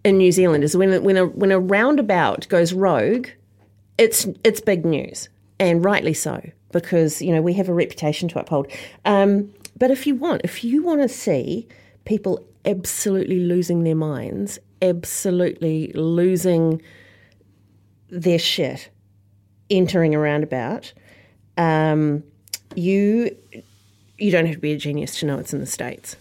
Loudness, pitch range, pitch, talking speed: -20 LUFS, 125-190 Hz, 165 Hz, 150 wpm